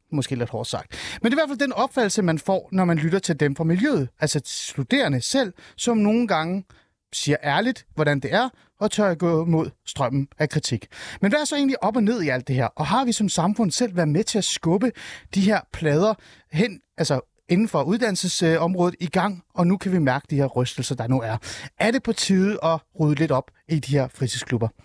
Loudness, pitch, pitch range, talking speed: -23 LUFS, 170 Hz, 140-210 Hz, 230 wpm